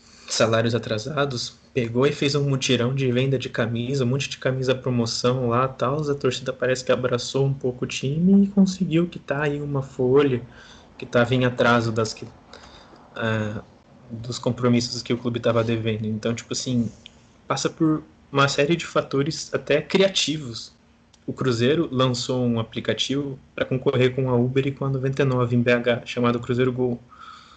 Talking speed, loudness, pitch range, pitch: 170 wpm, -23 LUFS, 120-140 Hz, 125 Hz